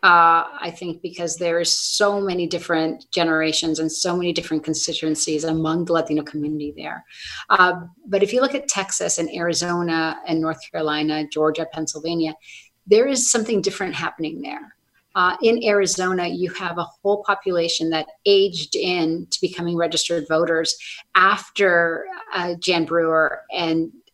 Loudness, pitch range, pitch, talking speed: -20 LUFS, 160-180 Hz, 170 Hz, 150 wpm